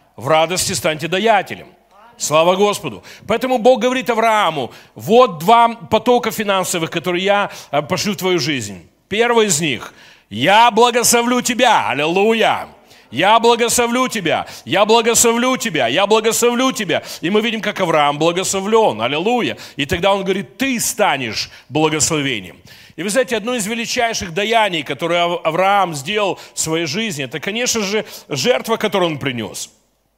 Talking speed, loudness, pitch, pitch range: 140 wpm, -16 LUFS, 200 Hz, 165-235 Hz